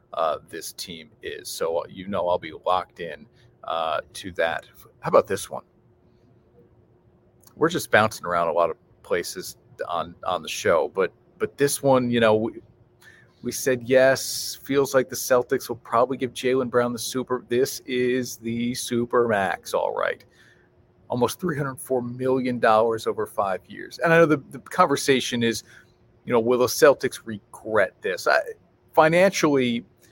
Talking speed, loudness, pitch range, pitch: 165 wpm, -23 LUFS, 120-155 Hz, 130 Hz